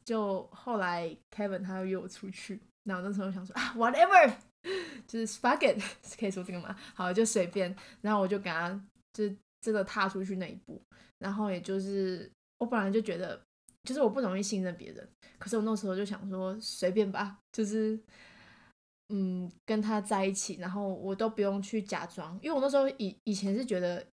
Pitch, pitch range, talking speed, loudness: 200 Hz, 190-220 Hz, 315 characters per minute, -32 LUFS